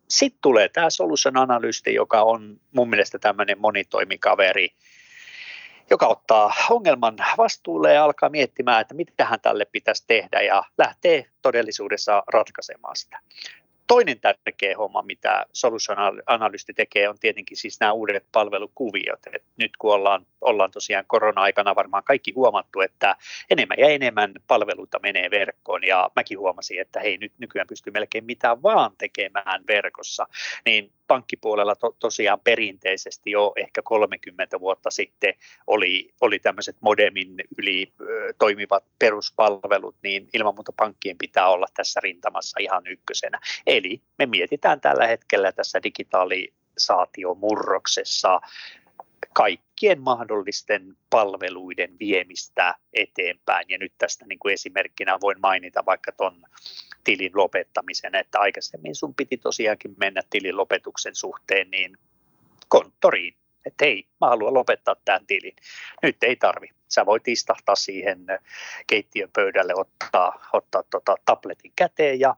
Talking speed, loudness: 130 wpm, -22 LUFS